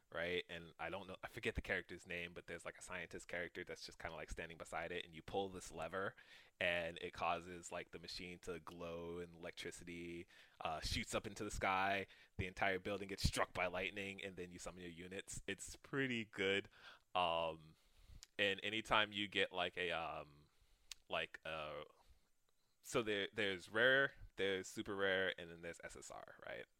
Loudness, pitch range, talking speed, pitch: -43 LUFS, 85-95 Hz, 180 wpm, 90 Hz